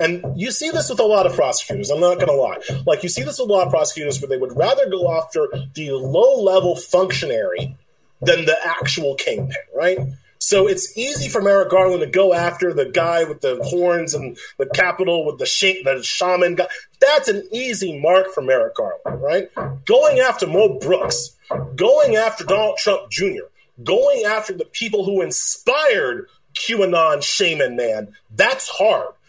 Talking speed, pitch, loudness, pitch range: 180 wpm, 190 Hz, -18 LUFS, 170-275 Hz